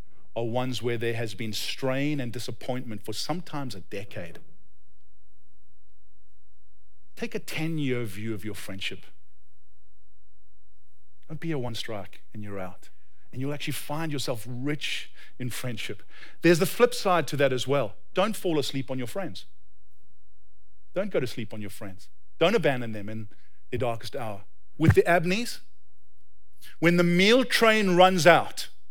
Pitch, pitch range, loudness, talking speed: 110 Hz, 95-145 Hz, -27 LUFS, 150 wpm